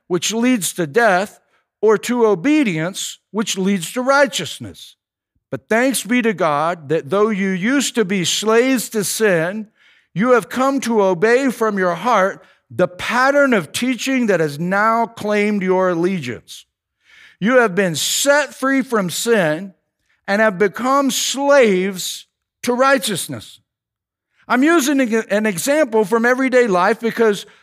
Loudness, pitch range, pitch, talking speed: -17 LUFS, 180-250 Hz, 215 Hz, 140 wpm